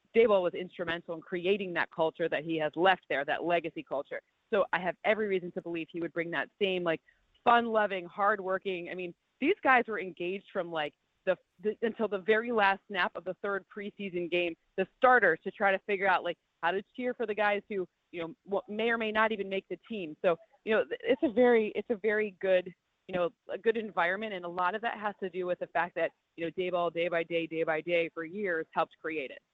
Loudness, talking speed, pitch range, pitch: -31 LUFS, 235 wpm, 170-215 Hz, 190 Hz